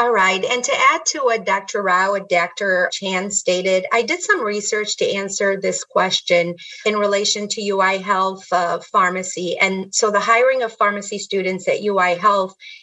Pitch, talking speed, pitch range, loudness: 200 Hz, 180 wpm, 185-215 Hz, -18 LUFS